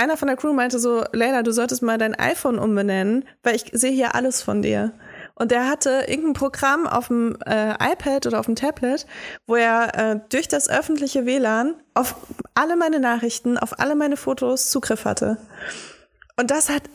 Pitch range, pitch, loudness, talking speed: 230-280 Hz, 255 Hz, -21 LUFS, 190 wpm